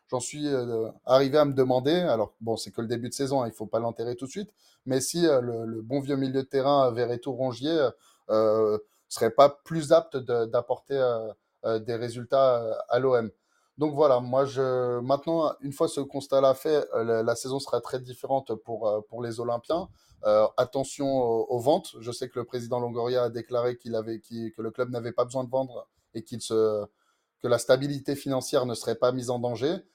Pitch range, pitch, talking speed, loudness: 115-135 Hz, 125 Hz, 210 wpm, -27 LUFS